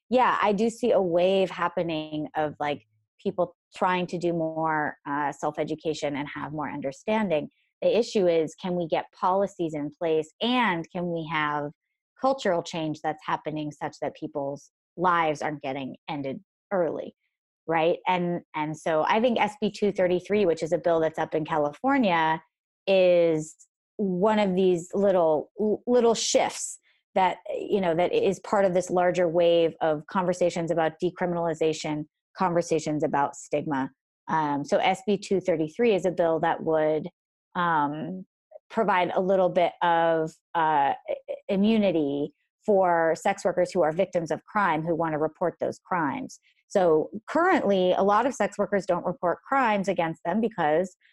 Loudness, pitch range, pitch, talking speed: -26 LUFS, 155-195 Hz, 175 Hz, 155 wpm